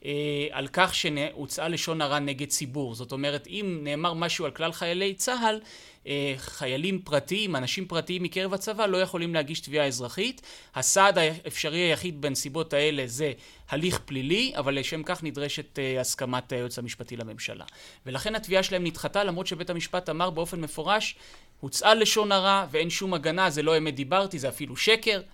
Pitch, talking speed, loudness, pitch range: 160 Hz, 155 wpm, -27 LUFS, 145-185 Hz